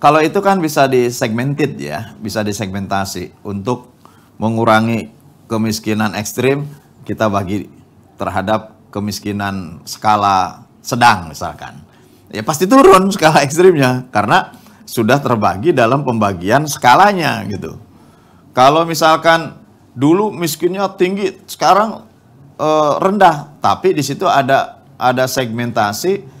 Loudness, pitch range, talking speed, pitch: -14 LUFS, 110-160 Hz, 100 wpm, 130 Hz